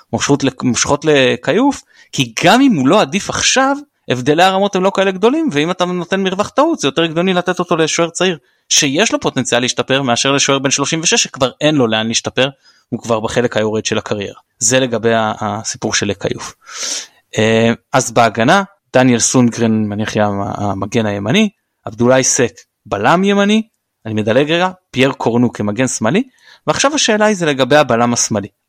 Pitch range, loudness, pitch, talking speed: 115-185 Hz, -14 LUFS, 135 Hz, 160 wpm